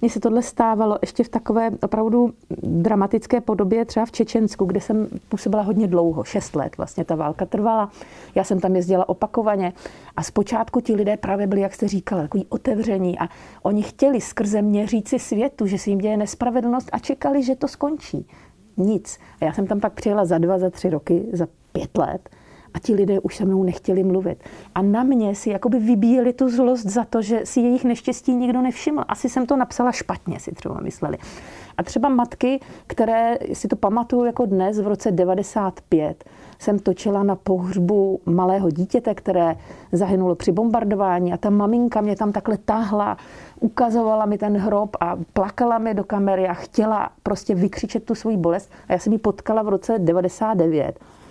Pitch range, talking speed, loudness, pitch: 190-235 Hz, 185 wpm, -21 LUFS, 210 Hz